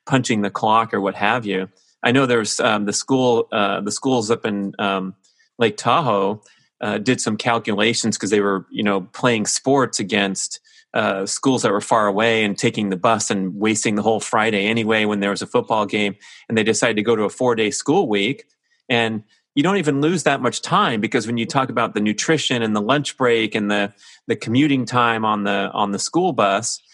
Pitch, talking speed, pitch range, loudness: 110 Hz, 215 wpm, 100-125 Hz, -19 LUFS